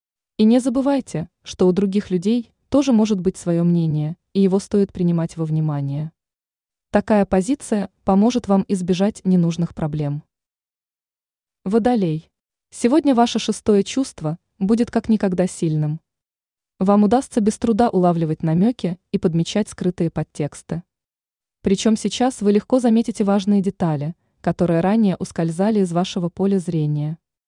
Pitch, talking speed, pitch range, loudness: 195 Hz, 125 wpm, 170-220 Hz, -20 LUFS